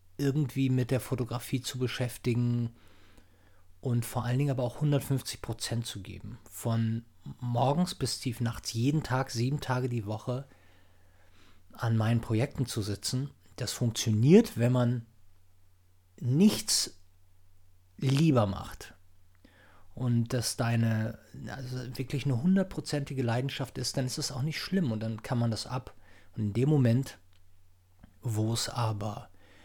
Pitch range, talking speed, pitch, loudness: 100-130 Hz, 135 wpm, 115 Hz, -30 LUFS